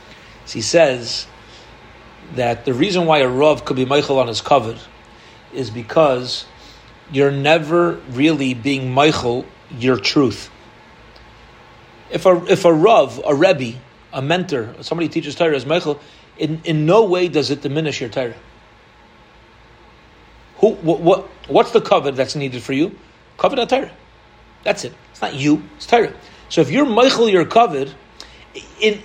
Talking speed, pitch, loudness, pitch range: 155 wpm, 145 Hz, -17 LUFS, 130-165 Hz